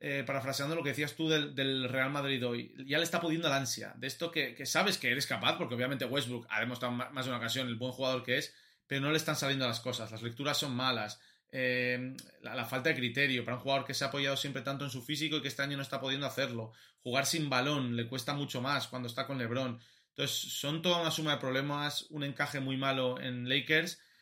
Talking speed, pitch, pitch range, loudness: 250 wpm, 135 Hz, 125-145 Hz, -33 LUFS